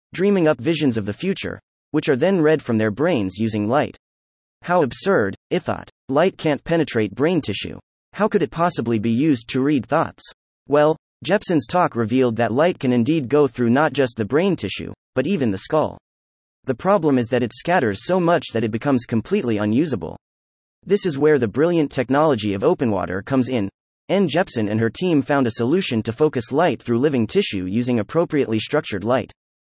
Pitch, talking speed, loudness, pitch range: 130 Hz, 190 wpm, -20 LUFS, 110-160 Hz